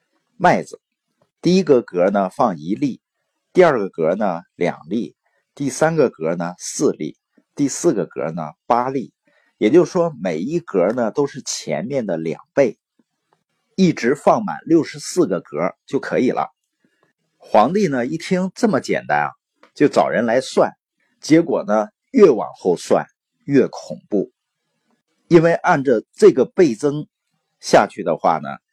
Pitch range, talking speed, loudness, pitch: 140-210 Hz, 205 characters per minute, -18 LUFS, 170 Hz